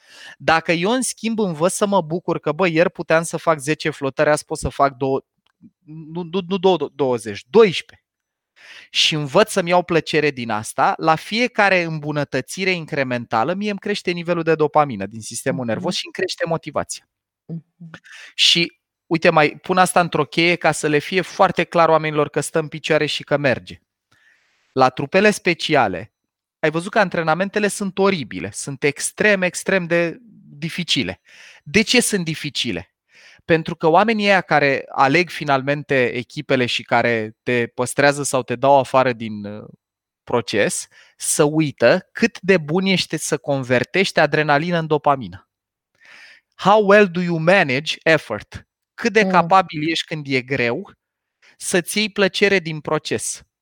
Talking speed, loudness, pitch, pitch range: 150 wpm, -18 LUFS, 160 Hz, 145-185 Hz